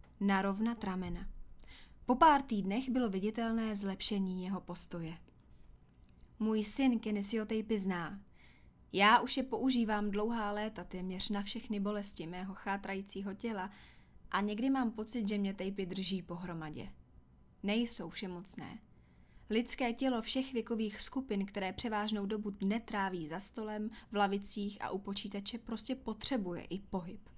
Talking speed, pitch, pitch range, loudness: 135 wpm, 205 Hz, 185-225 Hz, -36 LUFS